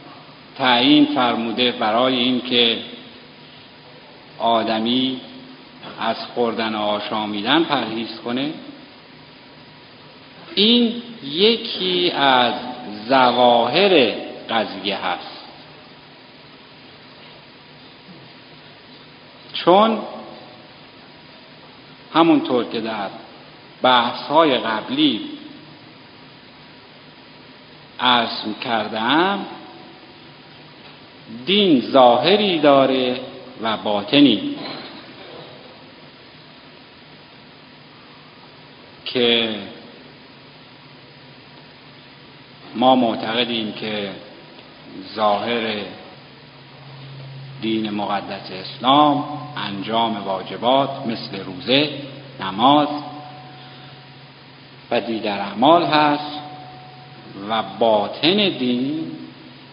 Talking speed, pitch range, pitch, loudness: 50 wpm, 115-150 Hz, 130 Hz, -18 LUFS